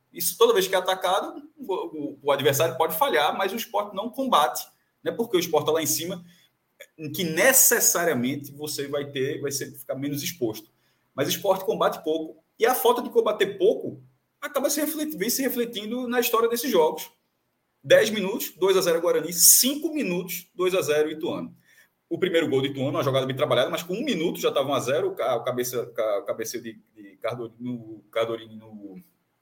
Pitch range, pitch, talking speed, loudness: 145-240 Hz, 180 Hz, 190 wpm, -24 LUFS